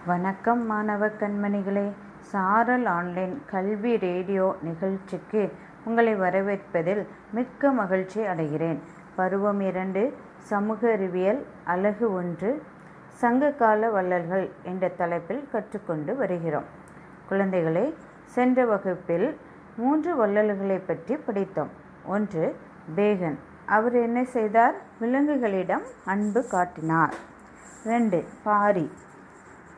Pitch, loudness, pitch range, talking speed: 200 Hz, -26 LUFS, 180-225 Hz, 85 wpm